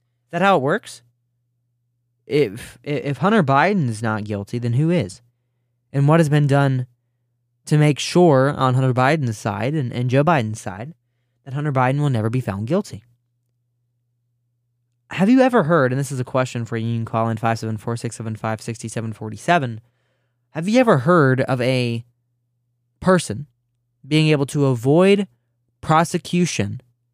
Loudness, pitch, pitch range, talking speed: -19 LUFS, 120 Hz, 120-145 Hz, 145 wpm